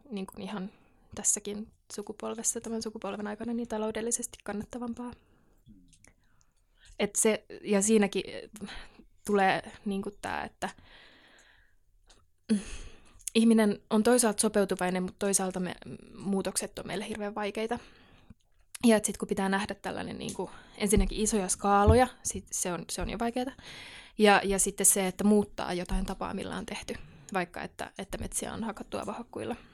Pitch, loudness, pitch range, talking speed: 205 Hz, -30 LUFS, 195-220 Hz, 135 wpm